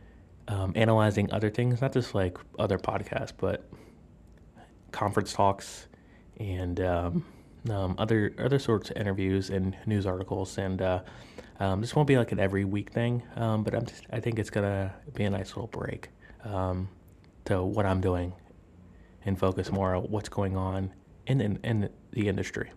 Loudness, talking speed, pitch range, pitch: -30 LUFS, 170 wpm, 95-110 Hz, 95 Hz